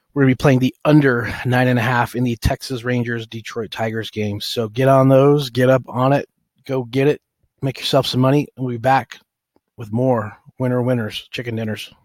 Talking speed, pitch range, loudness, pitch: 220 wpm, 120-135 Hz, -18 LUFS, 125 Hz